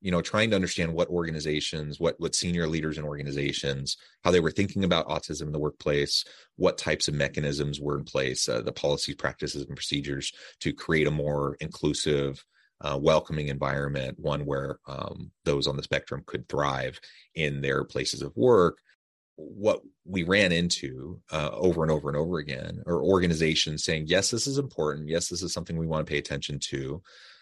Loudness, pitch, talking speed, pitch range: -28 LUFS, 75 Hz, 185 wpm, 70-85 Hz